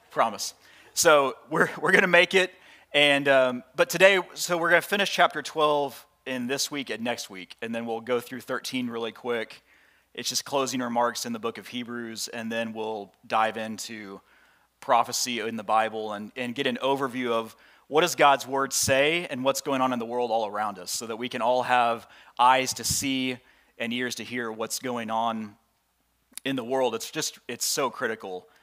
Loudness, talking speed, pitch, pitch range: -25 LUFS, 195 wpm, 125 Hz, 115-140 Hz